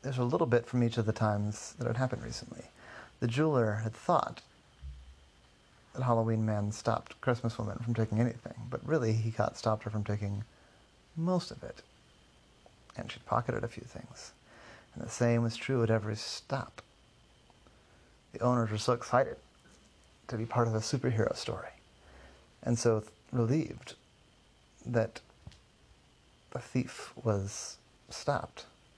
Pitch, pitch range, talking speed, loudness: 115 Hz, 105-120 Hz, 145 wpm, -33 LUFS